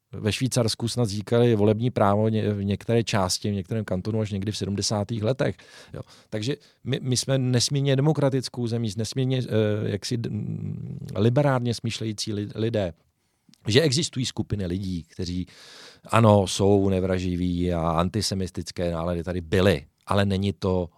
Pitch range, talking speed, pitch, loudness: 95-120 Hz, 140 wpm, 105 Hz, -25 LUFS